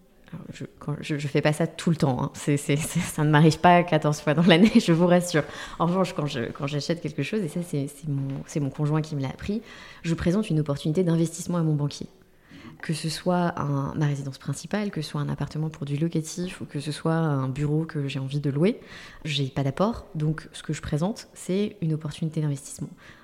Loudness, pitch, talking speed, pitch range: -25 LUFS, 155 Hz, 230 wpm, 145-175 Hz